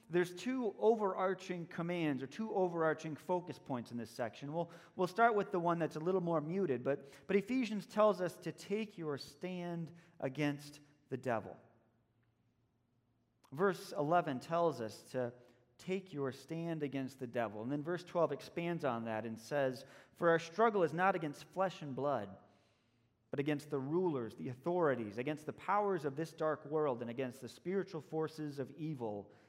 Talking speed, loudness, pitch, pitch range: 170 wpm, -38 LUFS, 150 Hz, 125-175 Hz